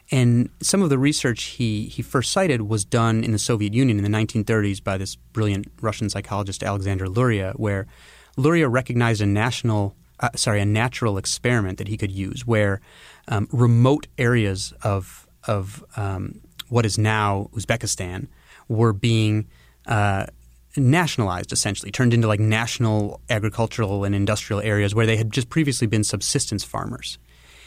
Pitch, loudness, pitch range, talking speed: 110 Hz, -22 LUFS, 100-120 Hz, 155 wpm